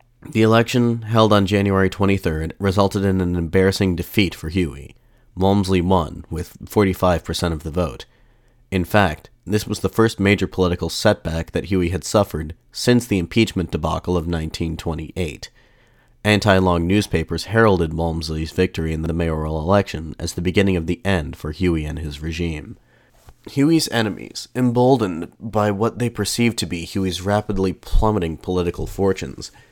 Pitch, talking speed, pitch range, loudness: 95 Hz, 150 wpm, 85-105 Hz, -20 LUFS